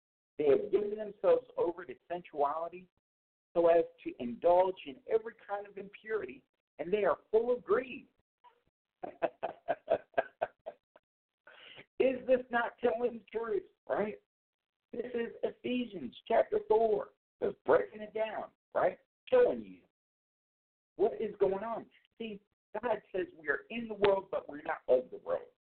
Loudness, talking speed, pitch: -33 LUFS, 140 wpm, 235 Hz